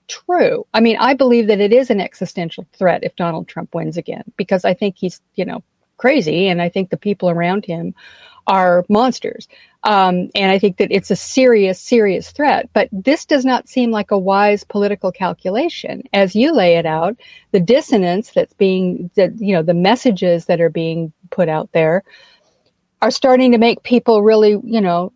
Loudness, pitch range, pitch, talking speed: -15 LUFS, 180-230 Hz, 200 Hz, 190 wpm